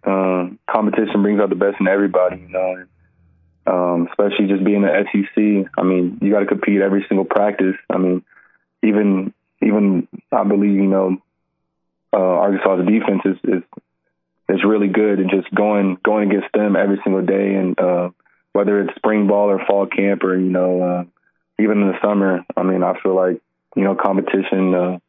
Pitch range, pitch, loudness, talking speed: 90-100 Hz, 95 Hz, -17 LUFS, 180 wpm